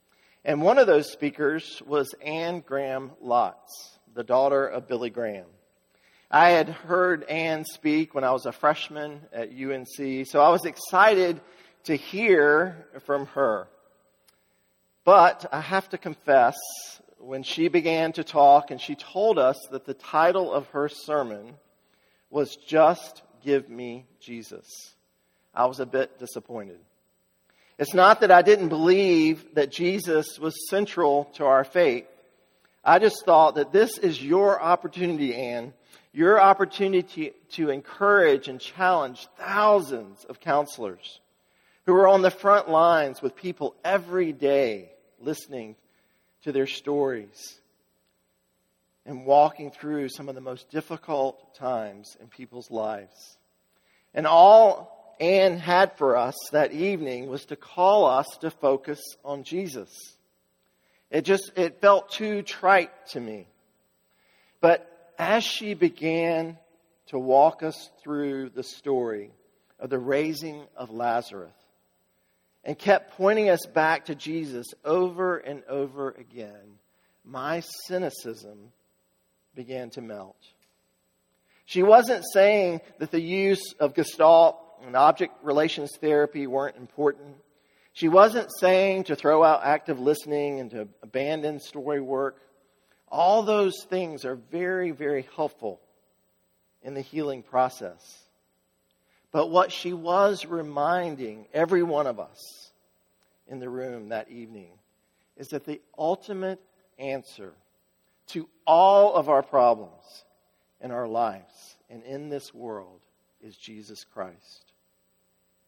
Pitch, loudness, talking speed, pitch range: 145 Hz, -23 LUFS, 130 wpm, 130-170 Hz